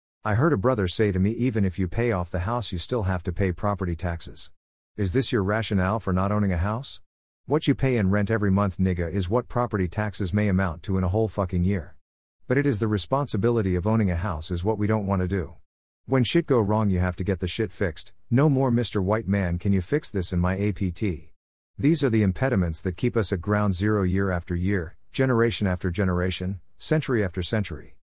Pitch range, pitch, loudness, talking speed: 90-110 Hz, 100 Hz, -25 LUFS, 230 wpm